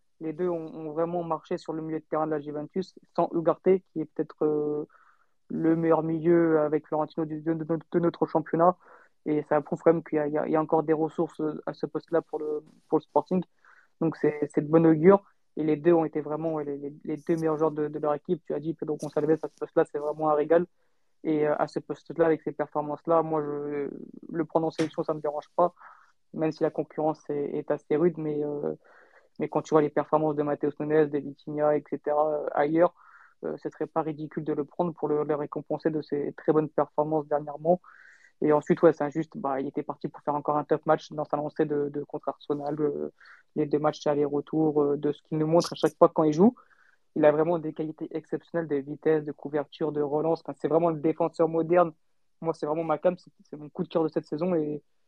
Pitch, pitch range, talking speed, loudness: 155 Hz, 150-165 Hz, 235 wpm, -27 LUFS